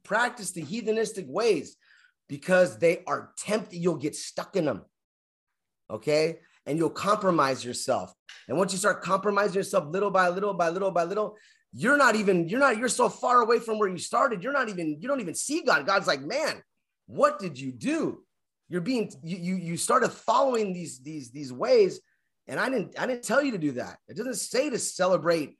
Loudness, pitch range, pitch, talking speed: -26 LUFS, 170-240 Hz, 195 Hz, 200 wpm